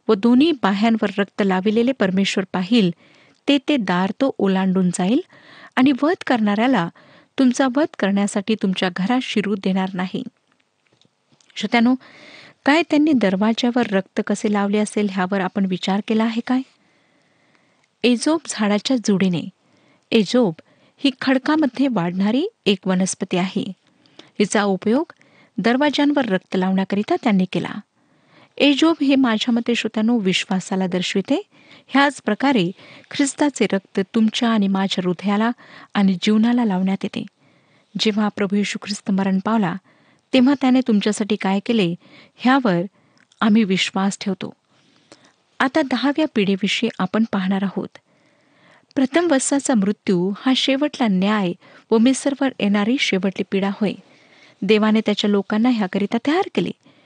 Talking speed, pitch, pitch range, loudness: 120 wpm, 215 Hz, 195-260 Hz, -19 LUFS